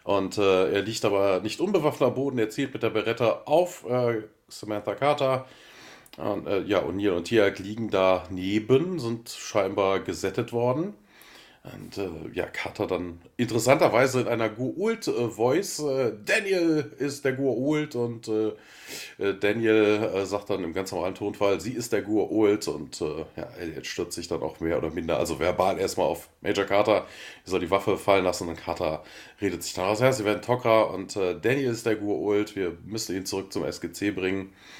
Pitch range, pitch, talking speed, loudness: 100-125 Hz, 110 Hz, 180 wpm, -26 LUFS